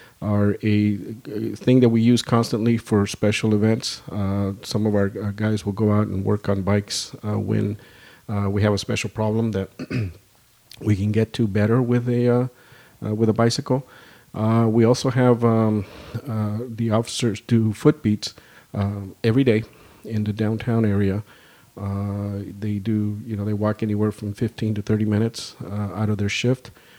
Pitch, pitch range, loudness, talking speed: 110 Hz, 105-115 Hz, -22 LUFS, 180 wpm